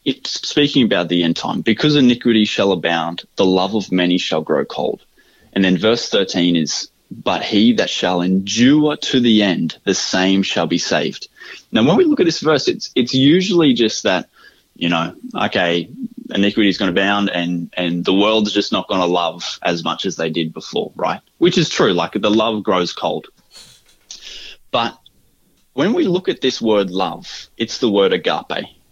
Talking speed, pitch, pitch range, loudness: 185 wpm, 100 Hz, 90-125 Hz, -17 LUFS